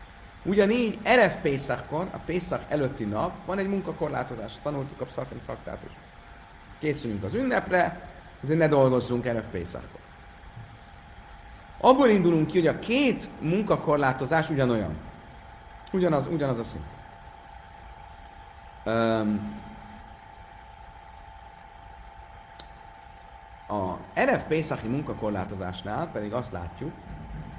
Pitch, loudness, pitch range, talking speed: 130 Hz, -27 LUFS, 105-165 Hz, 90 wpm